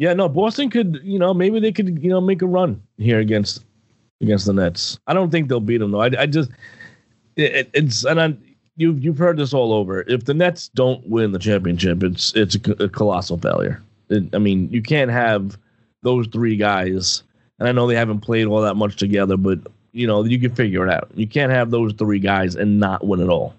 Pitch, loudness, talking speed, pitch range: 115 Hz, -19 LUFS, 230 wpm, 105-140 Hz